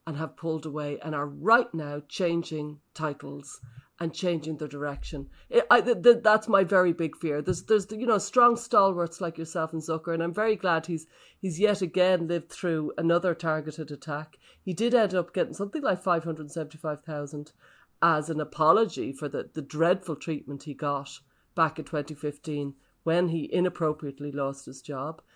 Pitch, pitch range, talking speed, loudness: 160 Hz, 150-180 Hz, 180 wpm, -27 LUFS